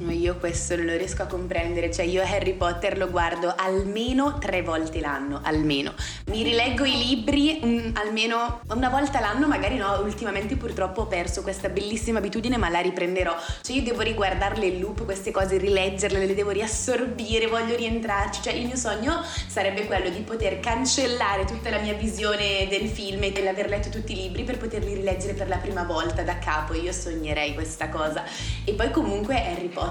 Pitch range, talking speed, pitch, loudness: 180-230 Hz, 185 wpm, 200 Hz, -25 LUFS